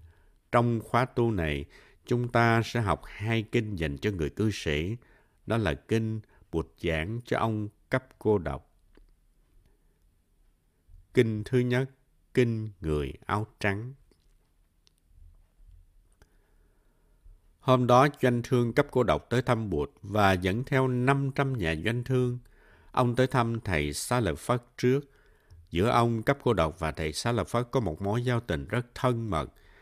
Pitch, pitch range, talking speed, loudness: 105 Hz, 85-125 Hz, 150 wpm, -28 LUFS